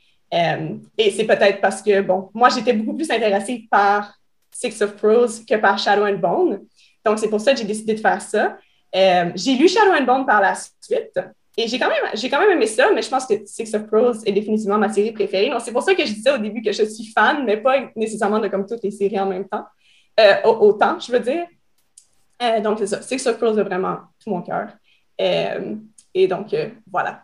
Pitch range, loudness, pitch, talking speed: 205-255 Hz, -19 LUFS, 220 Hz, 235 wpm